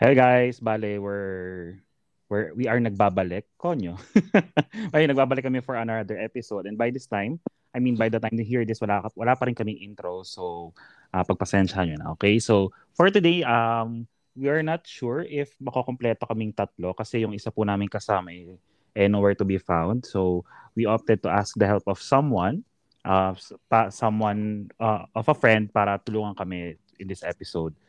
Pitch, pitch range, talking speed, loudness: 110 Hz, 100-120 Hz, 185 wpm, -25 LUFS